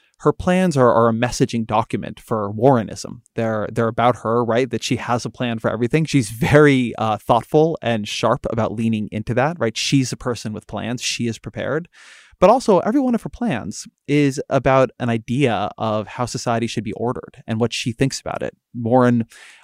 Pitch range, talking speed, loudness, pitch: 115-135 Hz, 195 wpm, -19 LUFS, 120 Hz